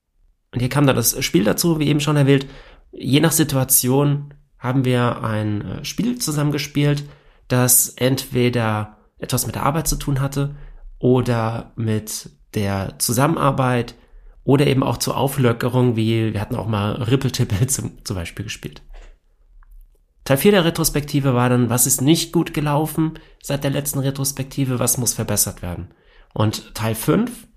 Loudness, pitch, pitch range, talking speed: -19 LUFS, 130 Hz, 115-145 Hz, 150 wpm